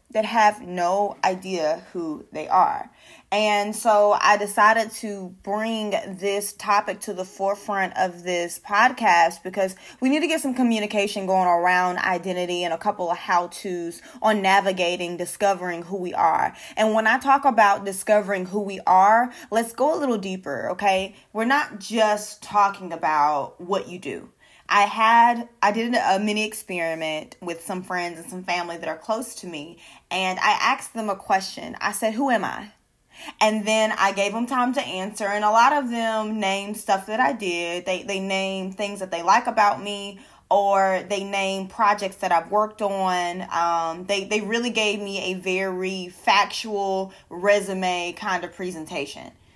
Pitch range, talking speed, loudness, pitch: 185-215 Hz, 175 wpm, -22 LUFS, 200 Hz